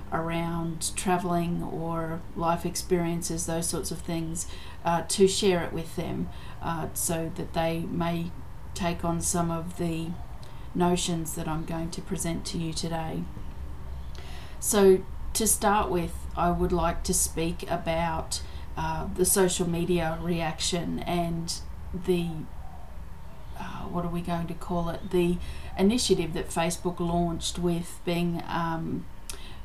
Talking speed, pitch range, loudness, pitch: 135 wpm, 165-175 Hz, -28 LUFS, 170 Hz